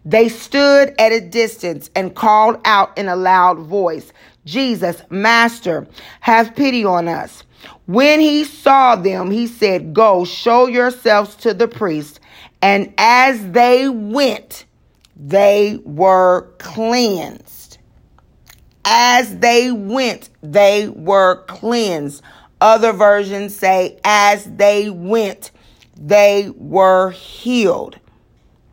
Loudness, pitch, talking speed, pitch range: -14 LUFS, 210 Hz, 110 wpm, 185-235 Hz